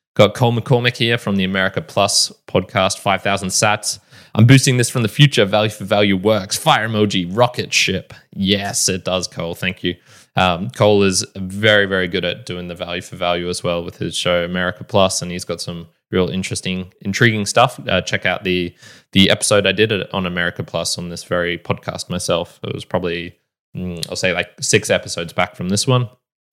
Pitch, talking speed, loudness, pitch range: 95 Hz, 195 wpm, -17 LUFS, 90-110 Hz